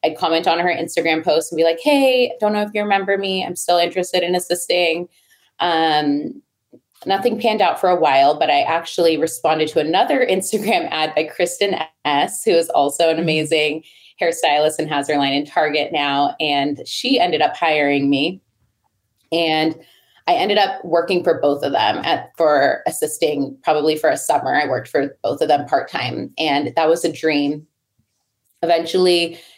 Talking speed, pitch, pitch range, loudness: 180 wpm, 165 Hz, 150-180 Hz, -18 LUFS